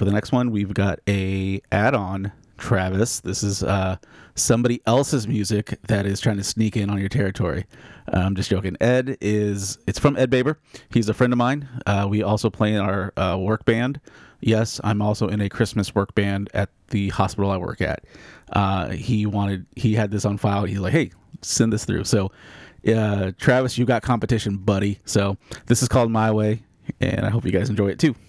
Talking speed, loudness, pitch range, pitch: 205 wpm, -22 LUFS, 100-115 Hz, 105 Hz